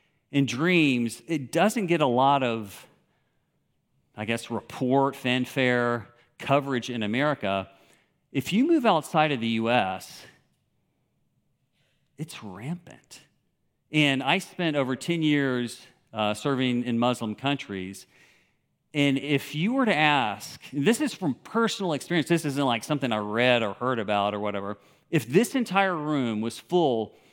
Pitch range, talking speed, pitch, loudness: 120-155 Hz, 140 wpm, 135 Hz, -25 LUFS